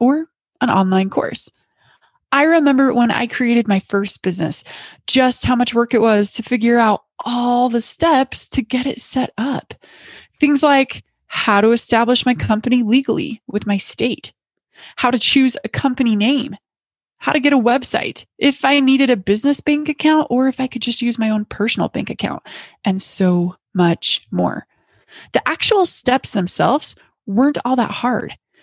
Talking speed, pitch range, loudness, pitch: 170 wpm, 220-270 Hz, -16 LUFS, 245 Hz